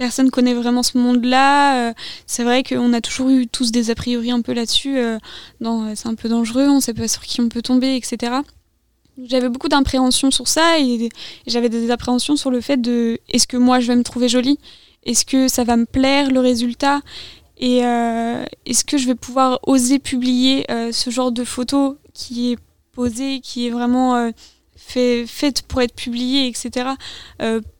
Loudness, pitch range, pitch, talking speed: -18 LUFS, 240-265 Hz, 250 Hz, 200 wpm